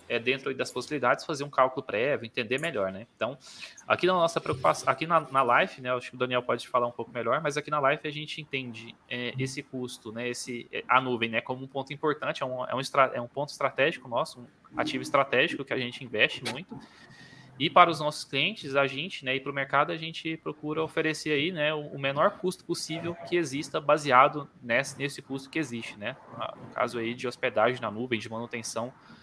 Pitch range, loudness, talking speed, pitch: 125-150 Hz, -28 LUFS, 220 wpm, 135 Hz